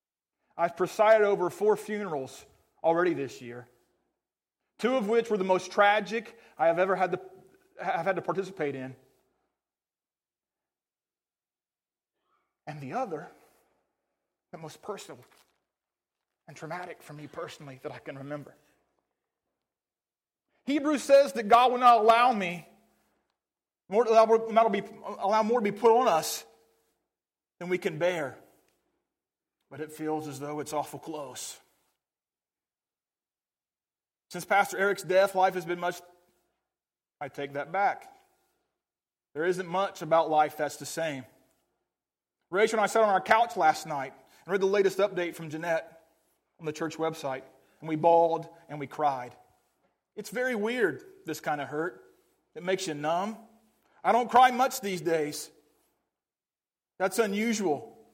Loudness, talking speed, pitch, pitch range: -27 LUFS, 140 wpm, 180 Hz, 155-220 Hz